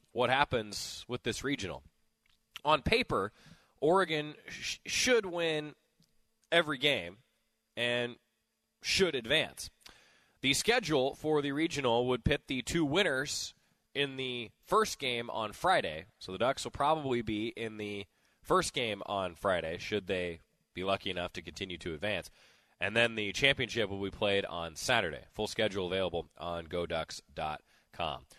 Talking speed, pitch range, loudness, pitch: 140 wpm, 95-140 Hz, -32 LUFS, 115 Hz